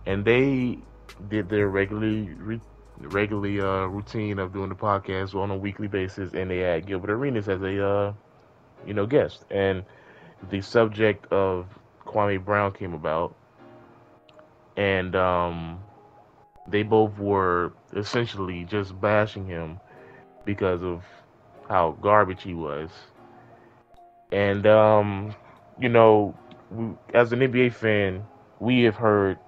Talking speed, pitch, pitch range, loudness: 125 wpm, 100 Hz, 95-110 Hz, -24 LUFS